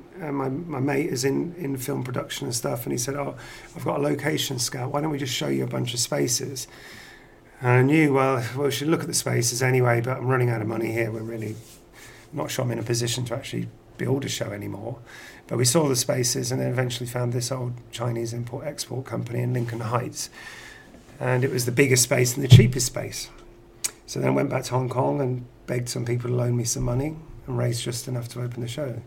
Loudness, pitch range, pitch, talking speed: -25 LUFS, 120-135 Hz, 125 Hz, 240 wpm